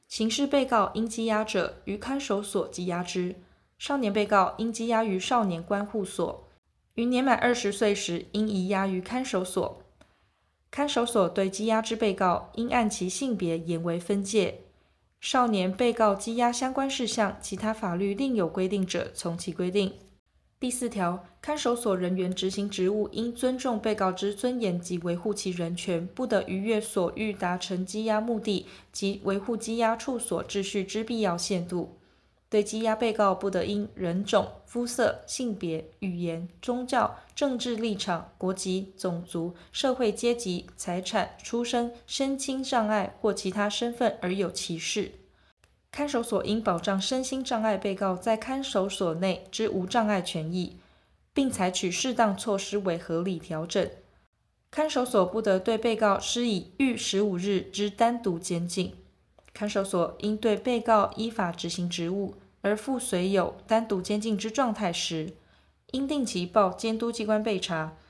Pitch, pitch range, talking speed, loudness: 205 Hz, 185-230 Hz, 240 characters per minute, -28 LUFS